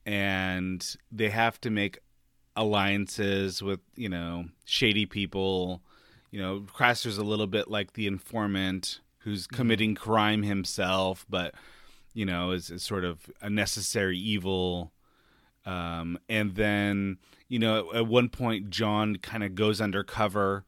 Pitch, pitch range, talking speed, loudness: 100 Hz, 95-110 Hz, 135 wpm, -29 LUFS